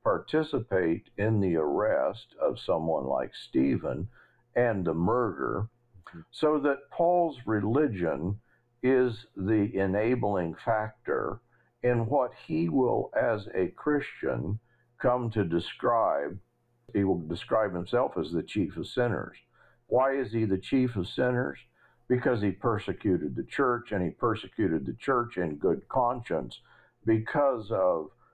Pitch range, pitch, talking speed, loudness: 95-125 Hz, 115 Hz, 125 wpm, -29 LUFS